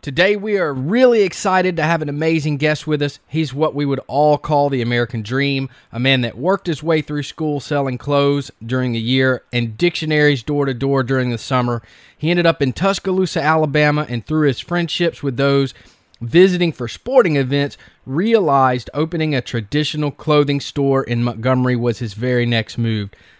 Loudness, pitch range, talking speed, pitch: -17 LUFS, 125-155 Hz, 180 wpm, 140 Hz